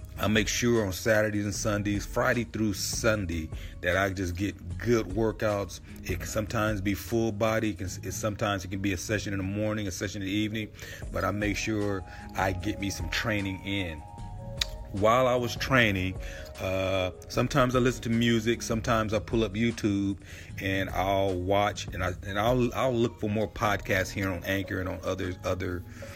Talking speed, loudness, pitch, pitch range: 190 wpm, -29 LUFS, 105 Hz, 95-110 Hz